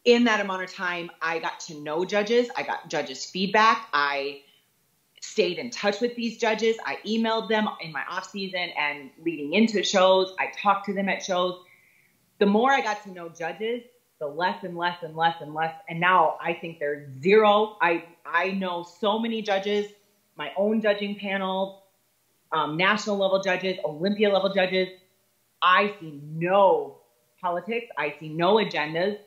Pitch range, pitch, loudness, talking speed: 170-205 Hz, 190 Hz, -25 LUFS, 170 wpm